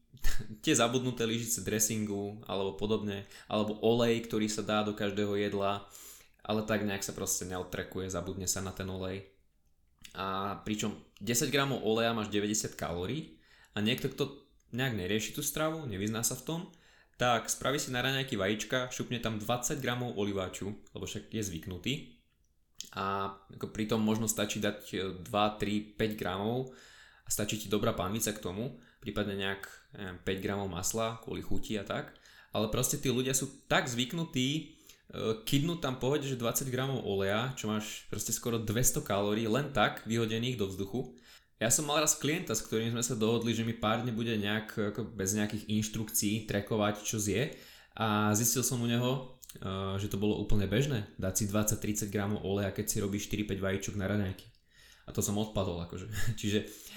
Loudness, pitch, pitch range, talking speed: -33 LUFS, 110 Hz, 100-120 Hz, 175 wpm